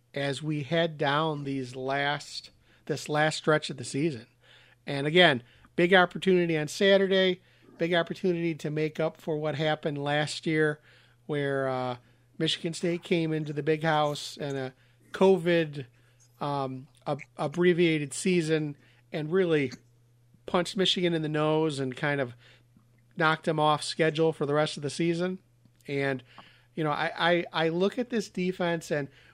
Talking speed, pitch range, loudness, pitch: 155 wpm, 135-170 Hz, -28 LUFS, 155 Hz